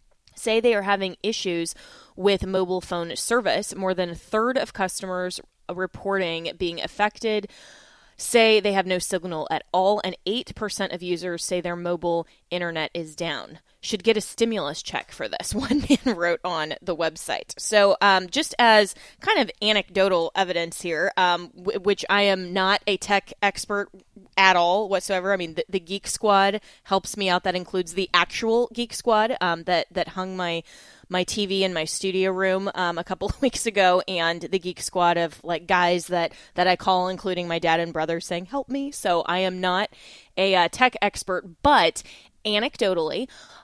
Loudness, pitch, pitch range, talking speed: -23 LUFS, 185 Hz, 175-205 Hz, 180 wpm